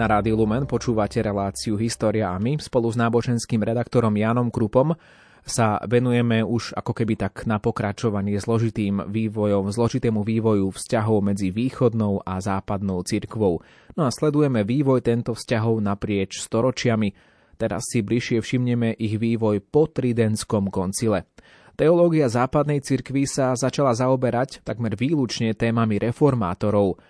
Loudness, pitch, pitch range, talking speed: -22 LUFS, 115 Hz, 105-125 Hz, 130 wpm